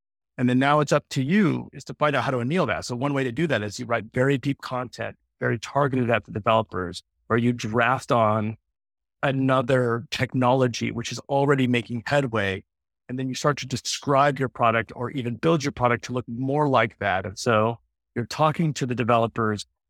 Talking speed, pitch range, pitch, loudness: 205 wpm, 115-135 Hz, 125 Hz, -24 LUFS